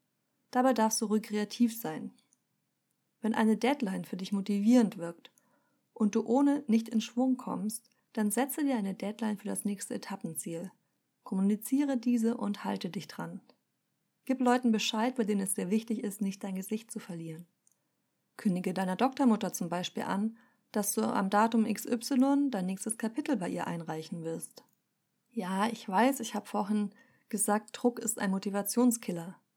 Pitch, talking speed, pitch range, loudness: 220 Hz, 160 wpm, 200-240 Hz, -31 LUFS